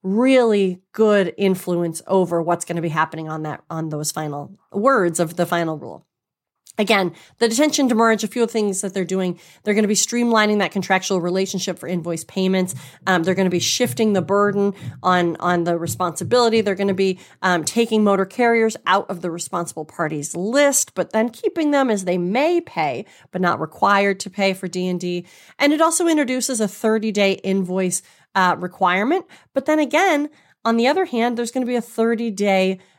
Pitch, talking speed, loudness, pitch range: 195 Hz, 190 wpm, -20 LUFS, 180-230 Hz